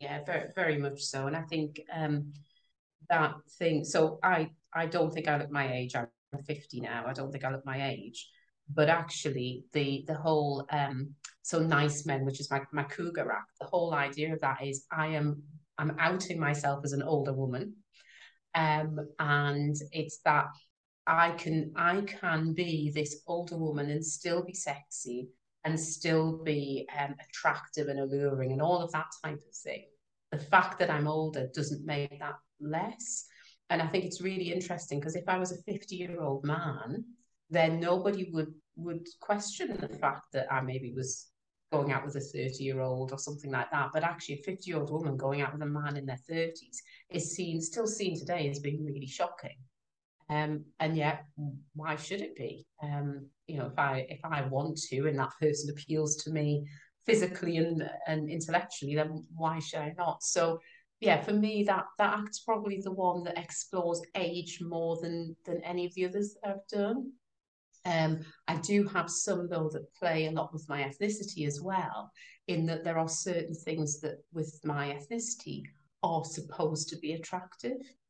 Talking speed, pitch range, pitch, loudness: 185 wpm, 145-170 Hz, 155 Hz, -33 LUFS